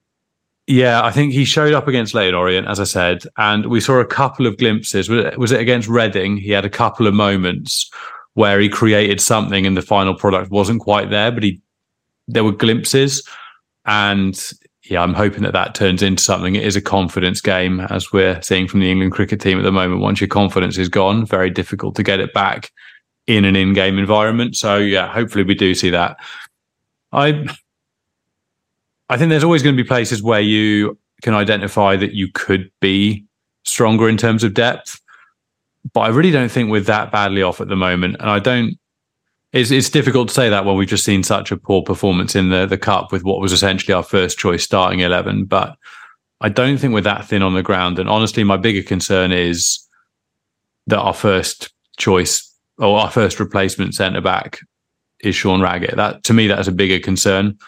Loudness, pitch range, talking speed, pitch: -15 LUFS, 95-115 Hz, 200 wpm, 100 Hz